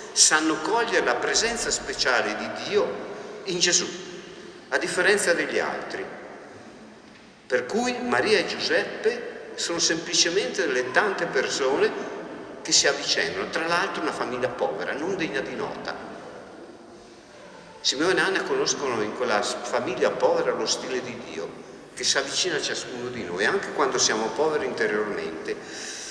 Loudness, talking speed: -24 LUFS, 135 wpm